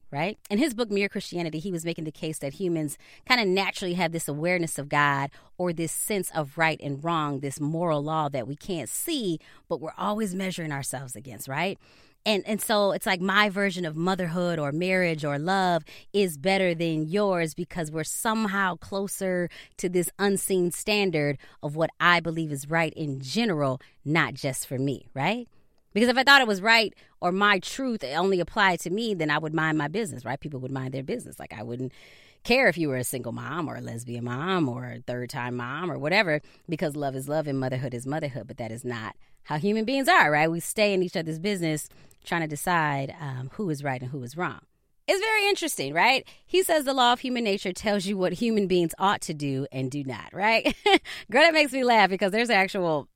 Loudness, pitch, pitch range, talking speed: -26 LUFS, 170 Hz, 145-200 Hz, 215 wpm